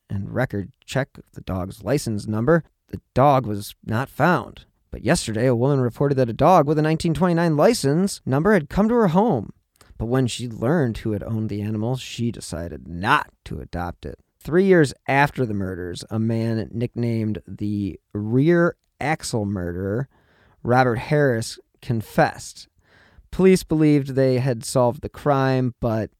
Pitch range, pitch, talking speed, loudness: 105-145 Hz, 120 Hz, 160 wpm, -21 LUFS